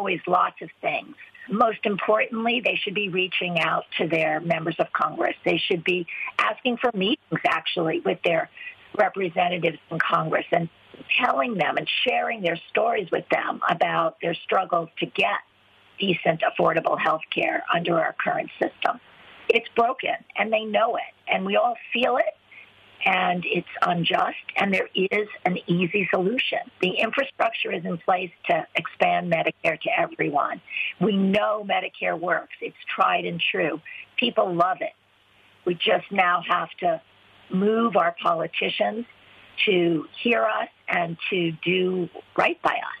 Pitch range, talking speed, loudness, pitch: 175-235 Hz, 150 wpm, -24 LUFS, 195 Hz